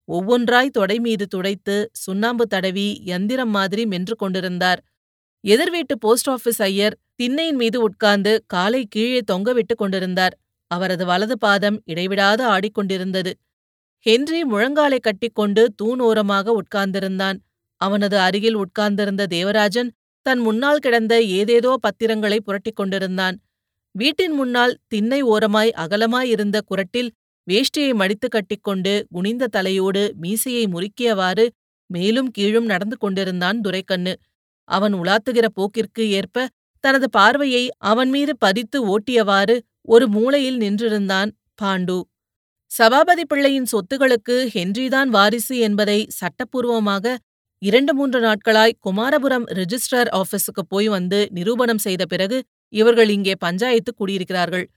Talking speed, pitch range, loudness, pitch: 105 wpm, 195-245 Hz, -19 LUFS, 215 Hz